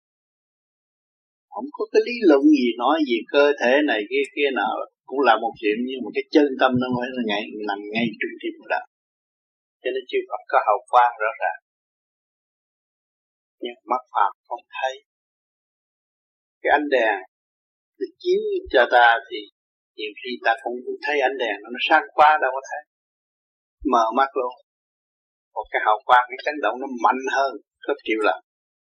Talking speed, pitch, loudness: 175 wpm, 205 Hz, -21 LUFS